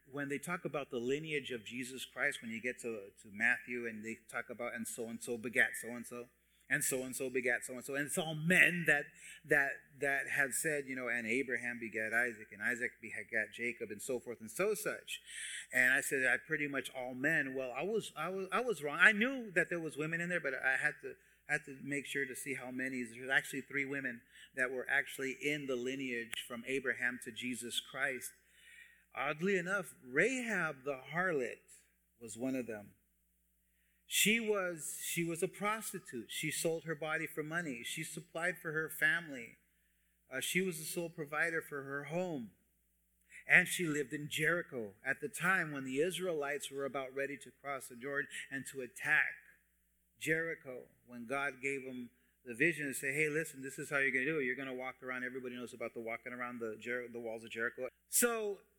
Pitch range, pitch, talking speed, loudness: 120-160 Hz, 135 Hz, 210 wpm, -36 LUFS